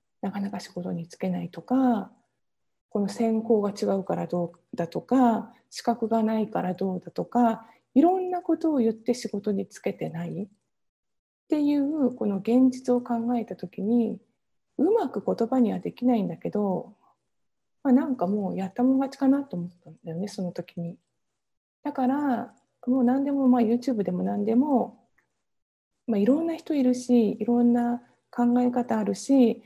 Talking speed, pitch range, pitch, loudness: 320 characters per minute, 200-250 Hz, 230 Hz, -26 LUFS